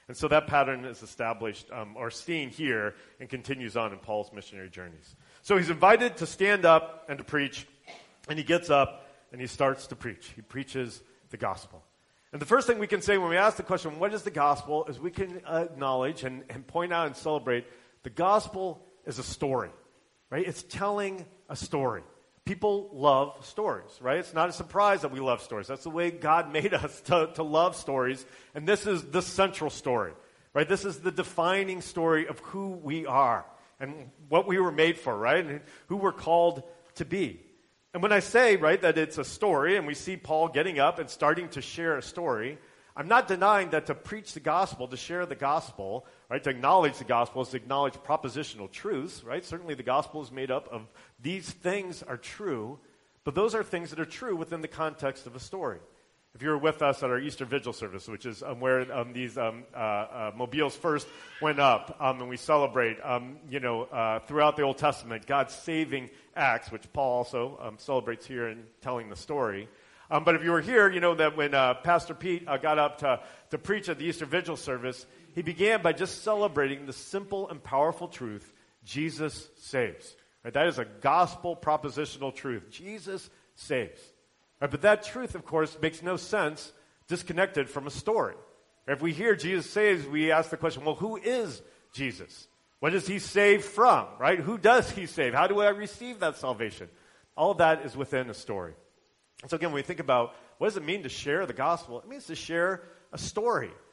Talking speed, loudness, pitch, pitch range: 205 wpm, -28 LUFS, 155 Hz, 130-180 Hz